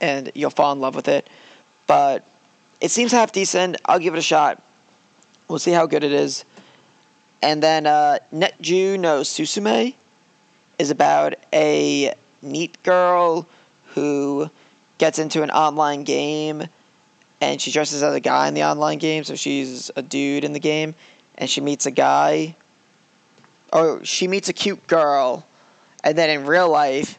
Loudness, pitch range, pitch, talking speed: -19 LUFS, 140-170 Hz, 150 Hz, 160 wpm